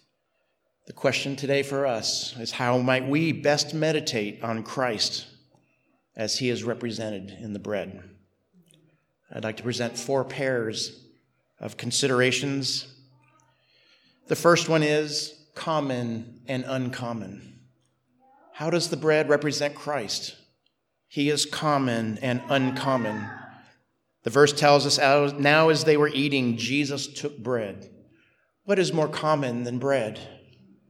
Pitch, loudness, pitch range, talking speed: 135 Hz, -25 LUFS, 115-145 Hz, 125 wpm